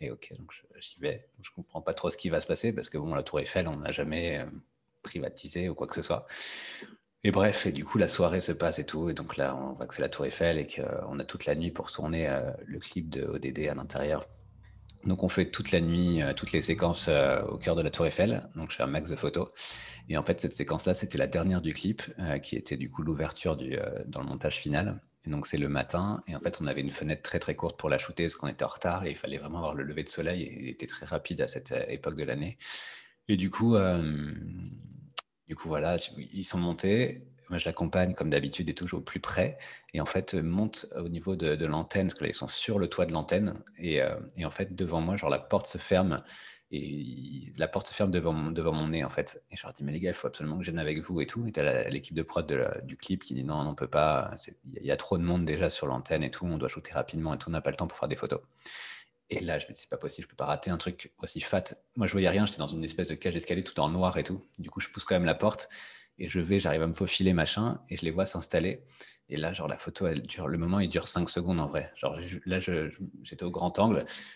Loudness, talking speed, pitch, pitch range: -31 LUFS, 280 wpm, 85 Hz, 80-95 Hz